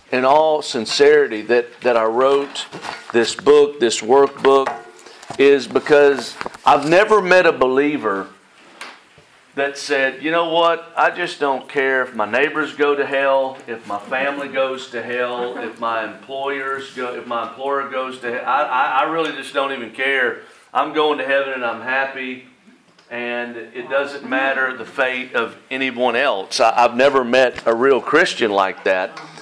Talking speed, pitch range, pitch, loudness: 165 wpm, 125-140 Hz, 135 Hz, -18 LUFS